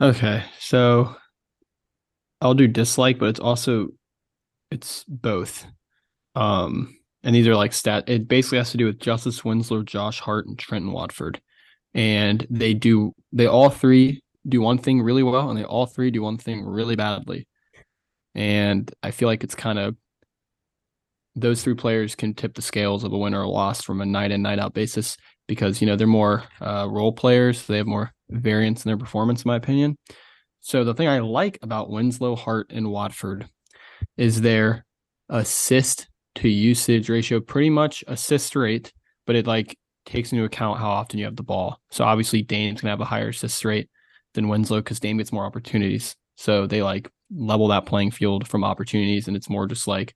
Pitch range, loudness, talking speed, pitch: 105-120 Hz, -22 LUFS, 185 wpm, 110 Hz